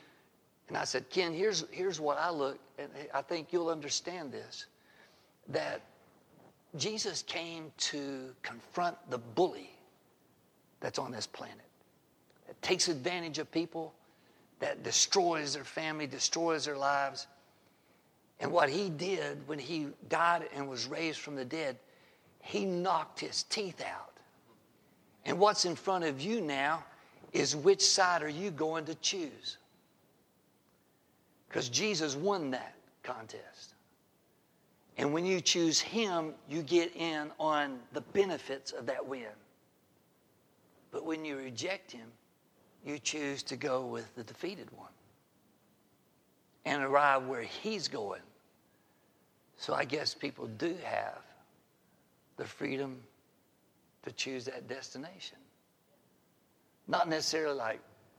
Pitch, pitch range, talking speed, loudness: 155 Hz, 140-175 Hz, 125 wpm, -34 LUFS